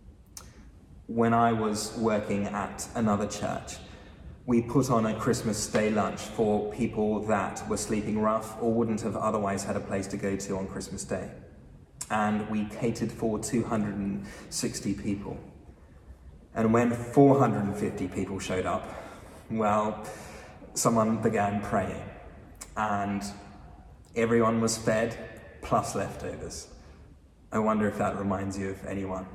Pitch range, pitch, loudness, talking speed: 95-110 Hz, 105 Hz, -29 LUFS, 130 wpm